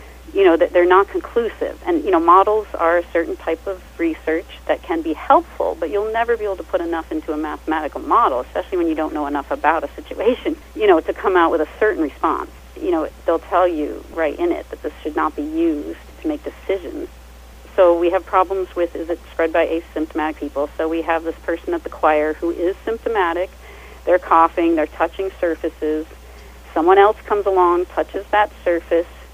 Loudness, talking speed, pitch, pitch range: -19 LUFS, 205 wpm, 175 Hz, 165-215 Hz